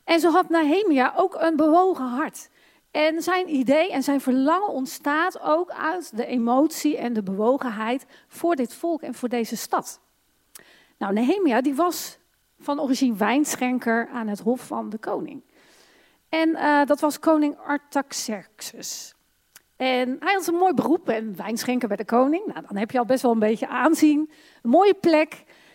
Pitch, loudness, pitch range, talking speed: 290 Hz, -23 LUFS, 250-325 Hz, 170 wpm